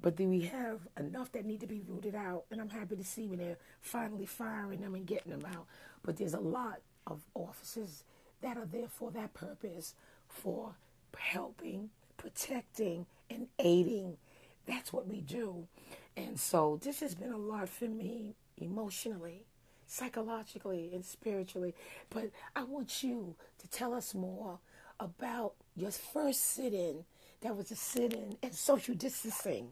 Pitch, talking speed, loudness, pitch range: 215 Hz, 155 wpm, -40 LUFS, 185-240 Hz